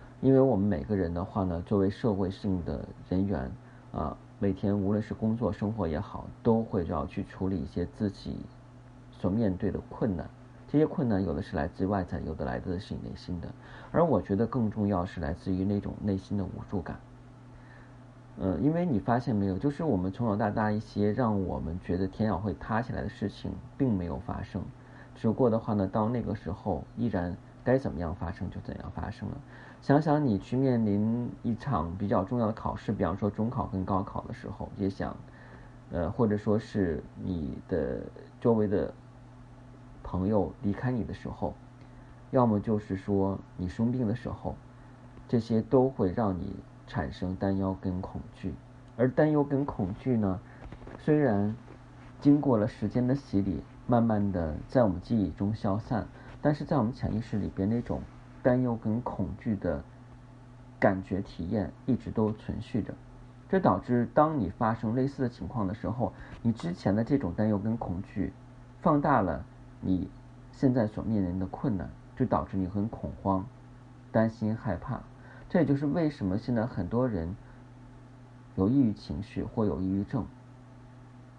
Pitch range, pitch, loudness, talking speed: 95-125 Hz, 110 Hz, -30 LUFS, 255 characters per minute